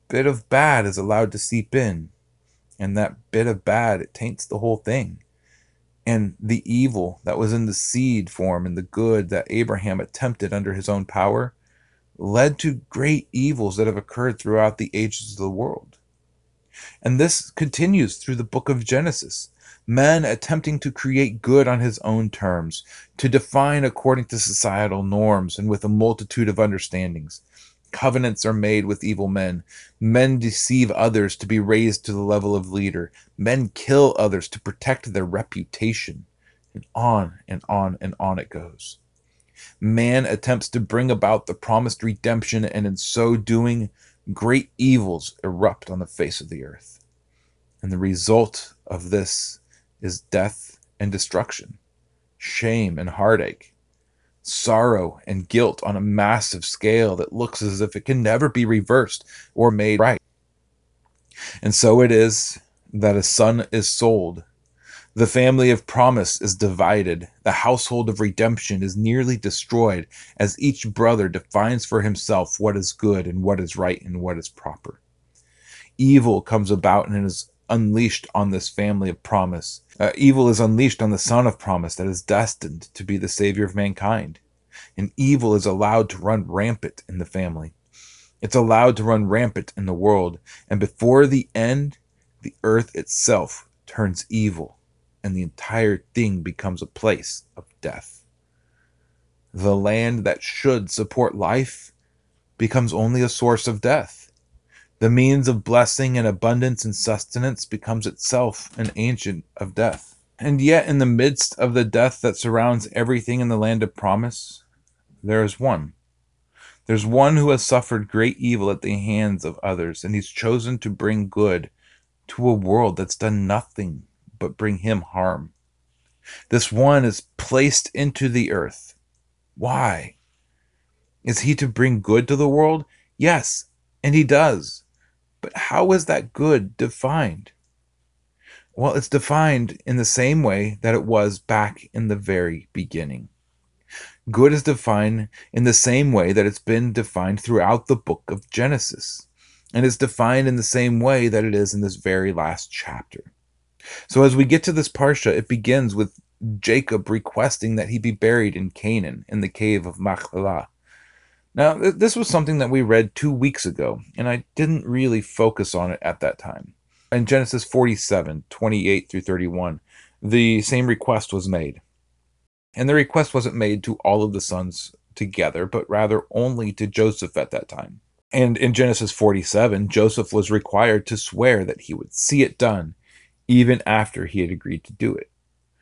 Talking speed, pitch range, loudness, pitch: 165 wpm, 95-120 Hz, -20 LUFS, 110 Hz